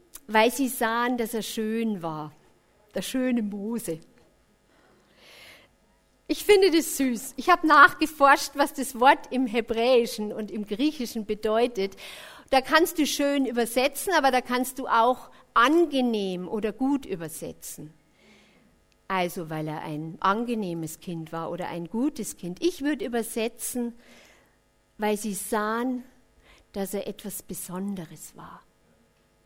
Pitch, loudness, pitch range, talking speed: 230 Hz, -25 LUFS, 195-265 Hz, 125 wpm